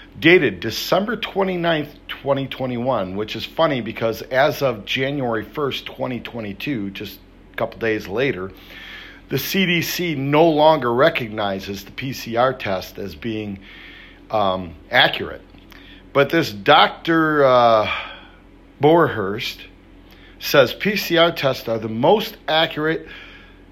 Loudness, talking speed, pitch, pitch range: -19 LUFS, 110 wpm, 130 Hz, 105-160 Hz